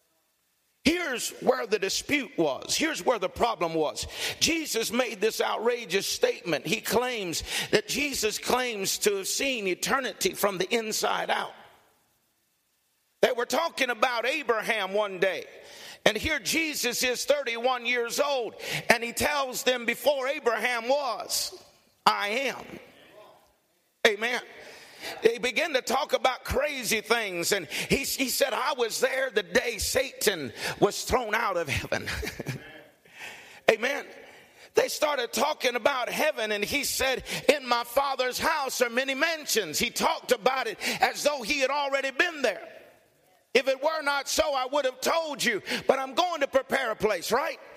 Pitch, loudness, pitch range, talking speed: 265 Hz, -27 LUFS, 235-305 Hz, 150 wpm